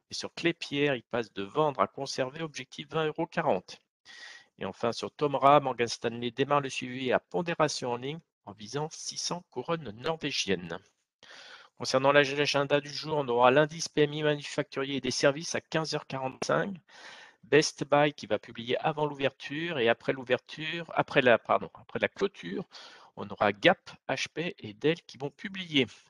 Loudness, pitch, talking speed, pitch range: -29 LUFS, 140 Hz, 160 wpm, 125-155 Hz